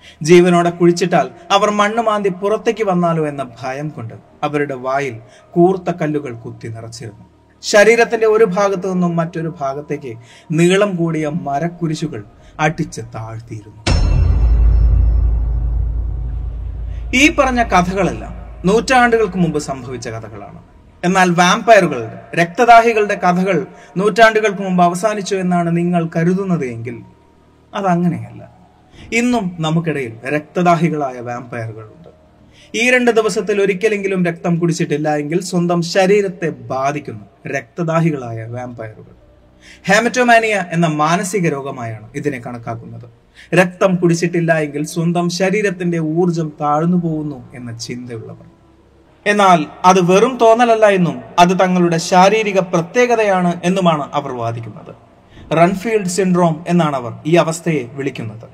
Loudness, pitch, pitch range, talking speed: -15 LUFS, 170 Hz, 130-190 Hz, 100 wpm